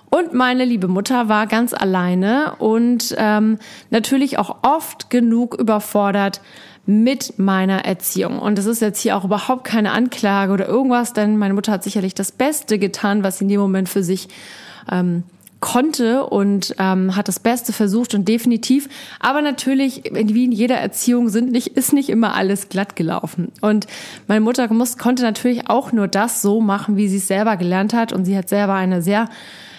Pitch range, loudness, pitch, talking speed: 200-245 Hz, -18 LUFS, 215 Hz, 180 wpm